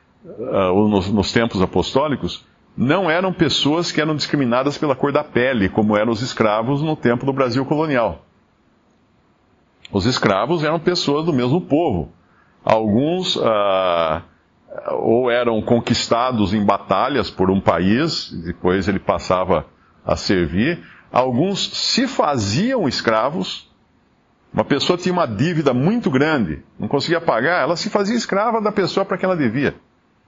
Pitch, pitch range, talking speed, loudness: 135 Hz, 105-175 Hz, 140 wpm, -18 LUFS